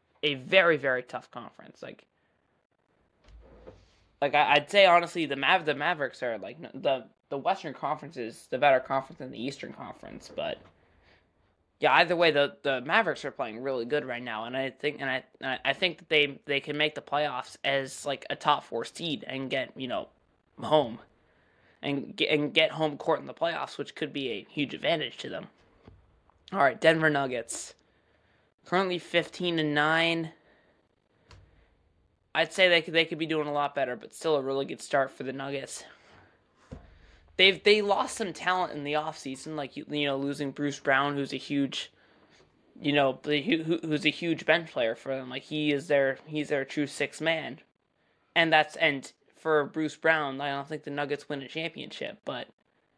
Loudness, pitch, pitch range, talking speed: -28 LUFS, 145 Hz, 135-160 Hz, 185 wpm